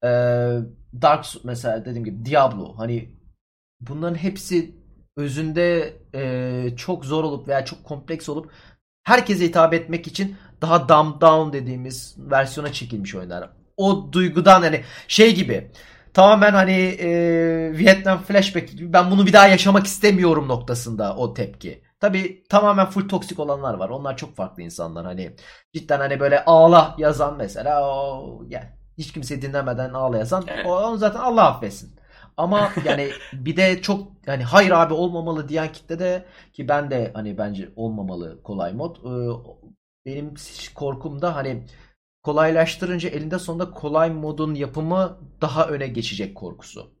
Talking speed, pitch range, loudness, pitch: 140 wpm, 125-180 Hz, -19 LUFS, 155 Hz